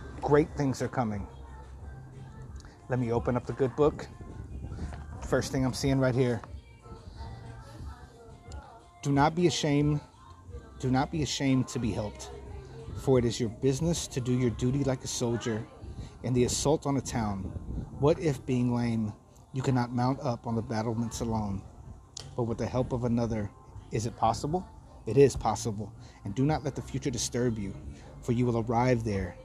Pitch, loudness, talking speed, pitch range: 120 Hz, -30 LUFS, 170 wpm, 105-130 Hz